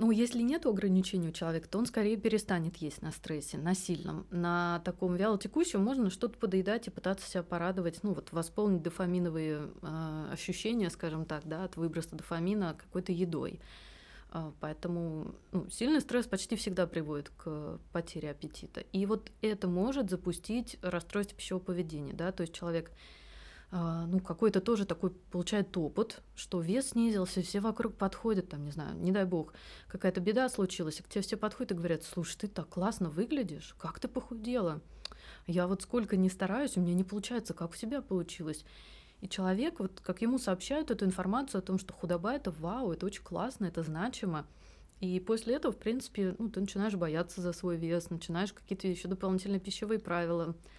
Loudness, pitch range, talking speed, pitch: -35 LUFS, 170-210 Hz, 175 wpm, 185 Hz